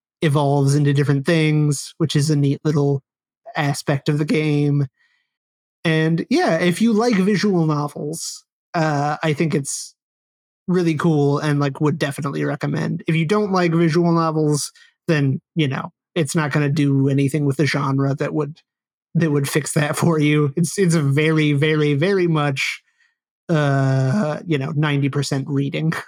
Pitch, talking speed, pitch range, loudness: 150 Hz, 160 wpm, 145-165 Hz, -19 LUFS